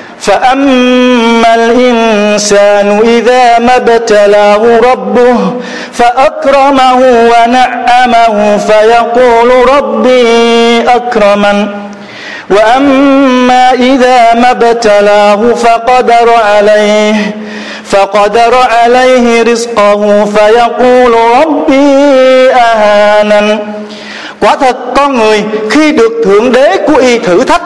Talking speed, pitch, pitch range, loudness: 75 wpm, 235 Hz, 210-250 Hz, -5 LUFS